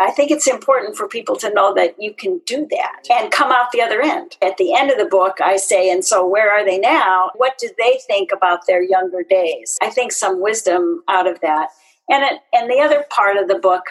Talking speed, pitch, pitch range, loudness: 245 wpm, 205 Hz, 185-265 Hz, -16 LUFS